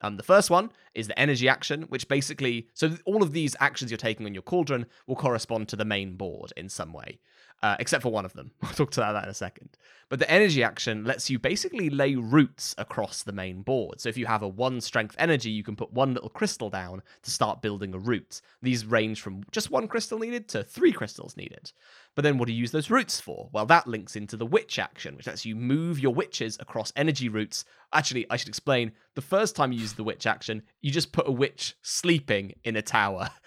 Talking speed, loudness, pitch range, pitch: 240 wpm, -27 LUFS, 110-150 Hz, 125 Hz